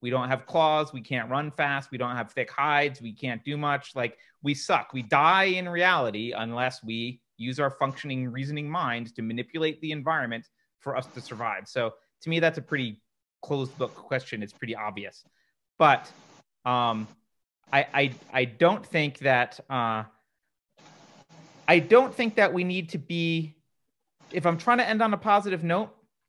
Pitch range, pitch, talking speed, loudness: 125-165 Hz, 140 Hz, 175 wpm, -26 LUFS